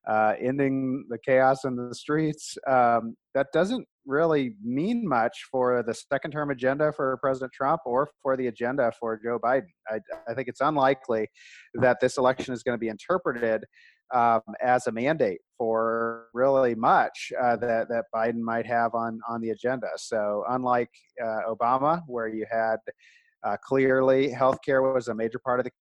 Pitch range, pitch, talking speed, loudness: 115-135 Hz, 125 Hz, 175 wpm, -26 LUFS